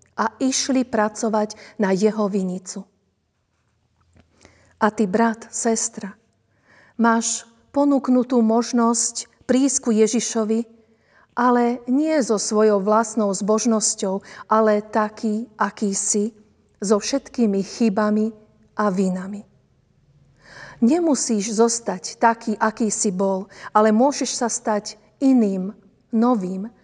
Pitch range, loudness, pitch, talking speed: 205-235 Hz, -21 LUFS, 220 Hz, 95 wpm